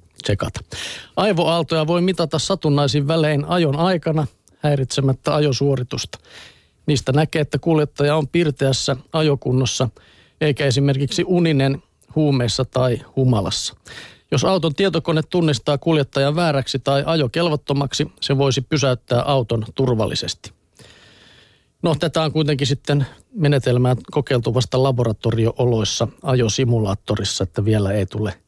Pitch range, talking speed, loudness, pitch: 125-155 Hz, 105 wpm, -19 LUFS, 140 Hz